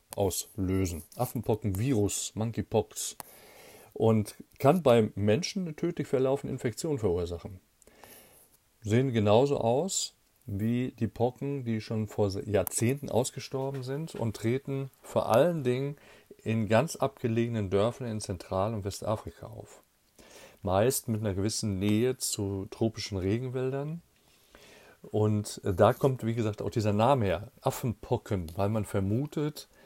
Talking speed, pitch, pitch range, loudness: 120 wpm, 110 Hz, 105-130 Hz, -30 LUFS